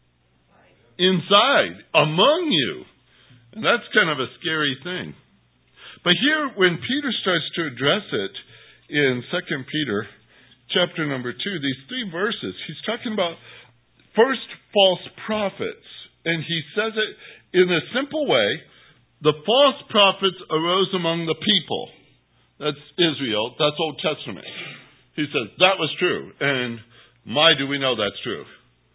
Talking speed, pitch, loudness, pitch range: 135 wpm, 165 Hz, -21 LUFS, 140-200 Hz